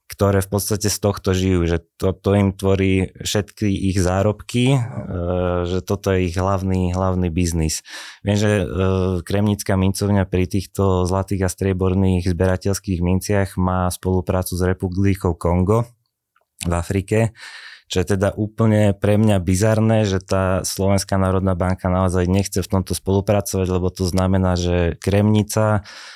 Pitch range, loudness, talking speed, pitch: 90-100 Hz, -20 LUFS, 140 wpm, 95 Hz